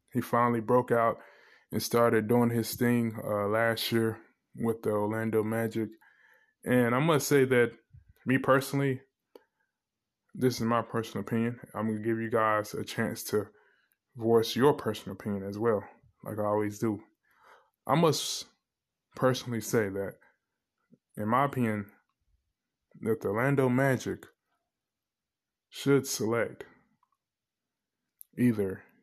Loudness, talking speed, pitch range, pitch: -29 LUFS, 125 wpm, 110-125 Hz, 115 Hz